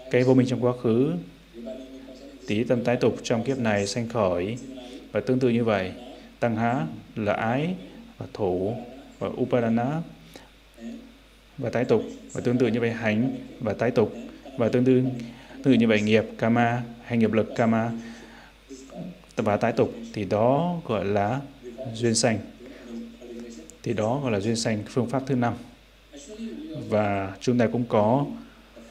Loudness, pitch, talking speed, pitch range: -25 LUFS, 120 Hz, 160 wpm, 115-130 Hz